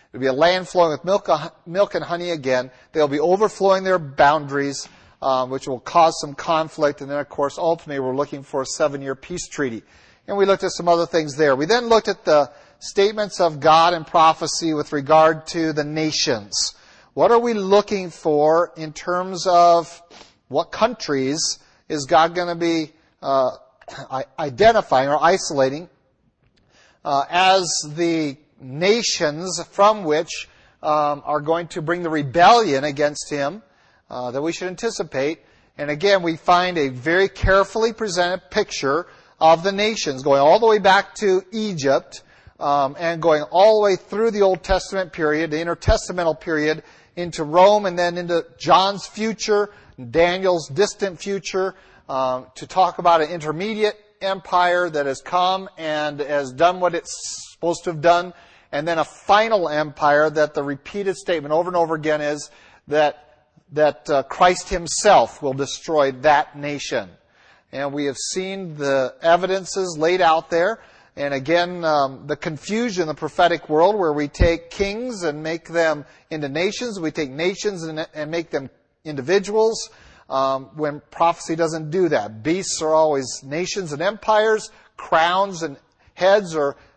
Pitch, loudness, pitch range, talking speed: 165 Hz, -20 LUFS, 150-185 Hz, 160 wpm